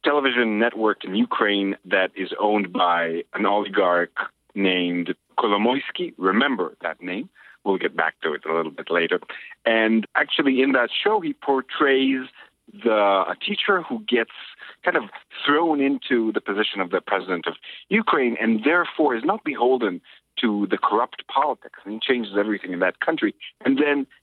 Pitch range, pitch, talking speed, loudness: 100-140 Hz, 115 Hz, 160 wpm, -22 LUFS